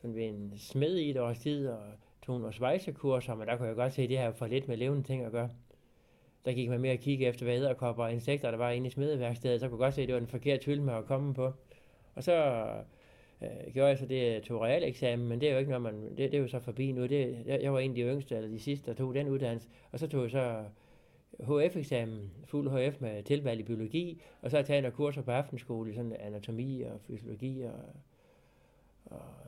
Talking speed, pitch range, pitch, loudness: 250 wpm, 120-135 Hz, 125 Hz, -34 LUFS